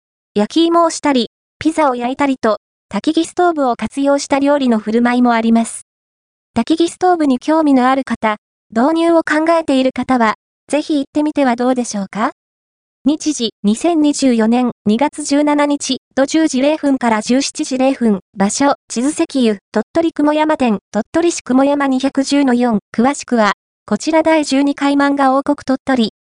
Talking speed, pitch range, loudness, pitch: 280 characters per minute, 230-295 Hz, -15 LUFS, 270 Hz